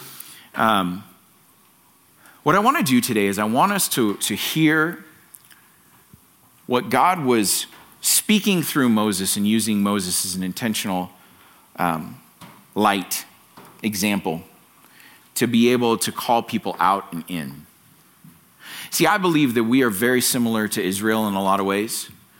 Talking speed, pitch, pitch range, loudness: 140 wpm, 110 Hz, 95-120 Hz, -20 LUFS